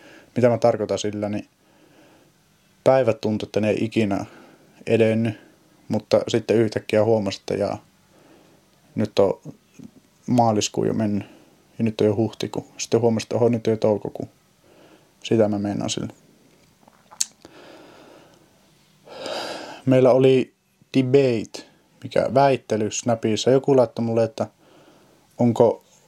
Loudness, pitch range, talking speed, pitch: -22 LUFS, 105-125 Hz, 115 wpm, 115 Hz